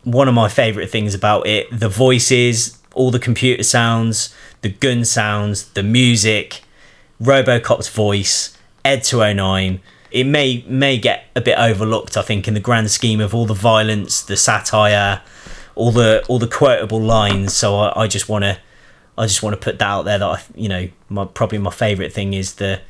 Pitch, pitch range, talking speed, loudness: 110 Hz, 100-120 Hz, 185 wpm, -16 LUFS